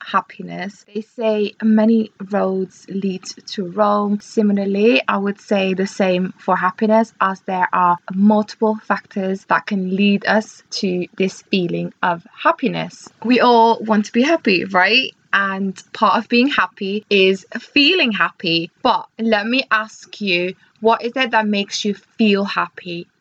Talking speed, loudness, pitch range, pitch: 150 wpm, -17 LUFS, 190-220 Hz, 205 Hz